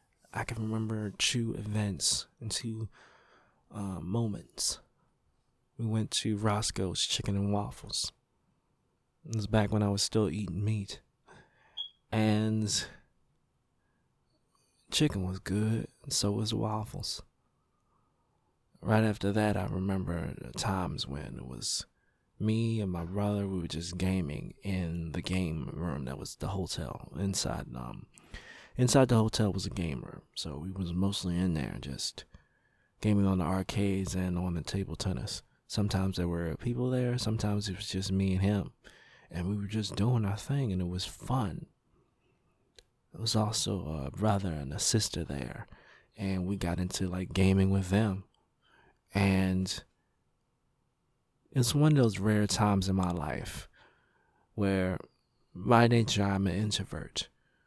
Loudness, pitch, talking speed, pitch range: -32 LUFS, 100 Hz, 145 wpm, 95-110 Hz